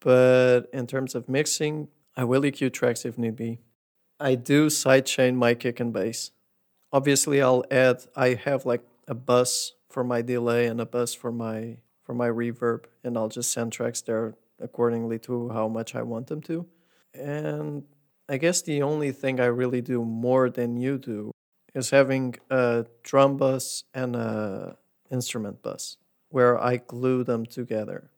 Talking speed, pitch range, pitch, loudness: 170 wpm, 120-135 Hz, 125 Hz, -25 LUFS